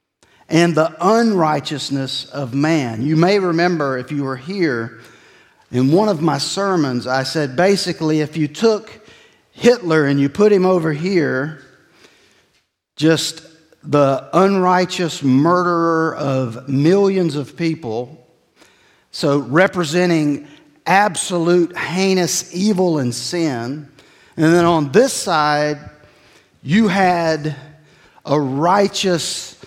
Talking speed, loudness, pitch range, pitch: 110 wpm, -17 LUFS, 145-180 Hz, 160 Hz